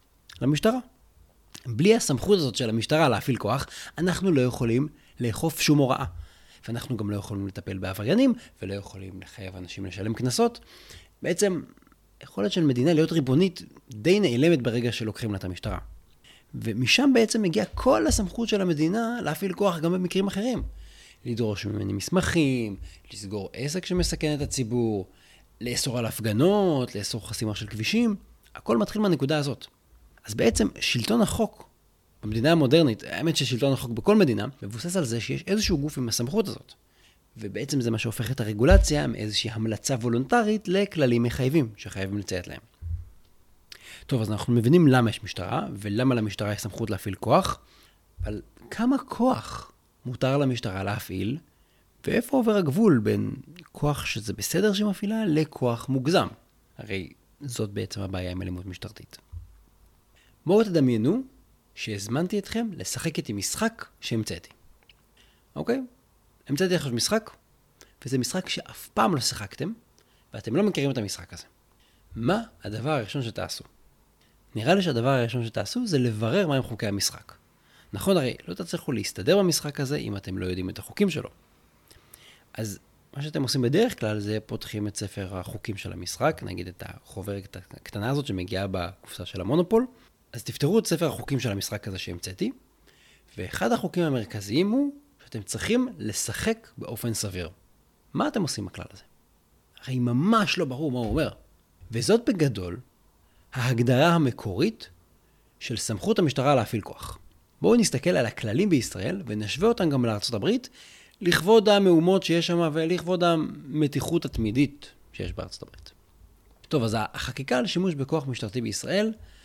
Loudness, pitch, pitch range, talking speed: -26 LUFS, 125 Hz, 100-165 Hz, 140 wpm